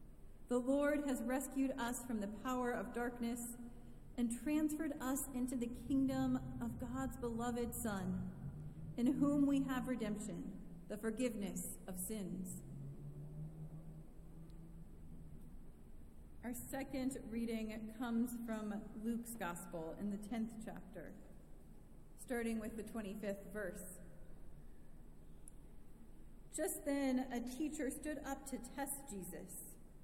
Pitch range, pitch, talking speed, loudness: 165-255 Hz, 220 Hz, 110 wpm, -42 LUFS